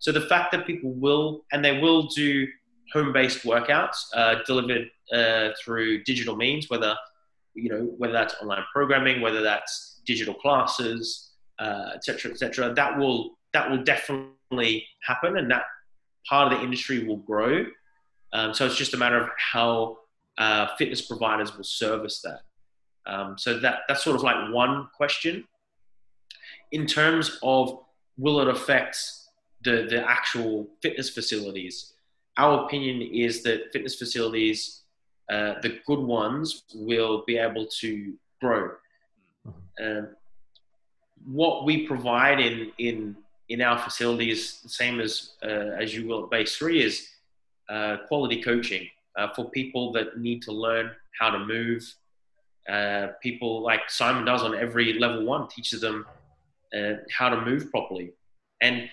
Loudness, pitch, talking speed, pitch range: -25 LUFS, 120 Hz, 150 wpm, 110-135 Hz